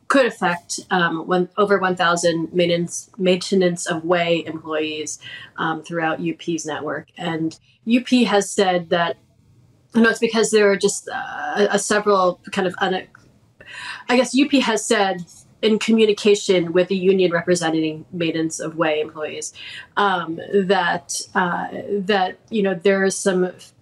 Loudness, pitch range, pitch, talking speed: -20 LUFS, 165-205 Hz, 185 Hz, 150 wpm